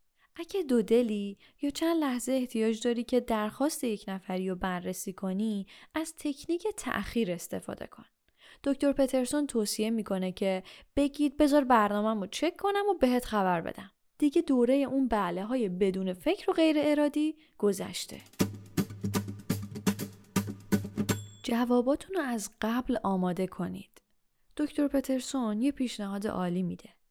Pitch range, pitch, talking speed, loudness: 190-285 Hz, 230 Hz, 130 wpm, -30 LUFS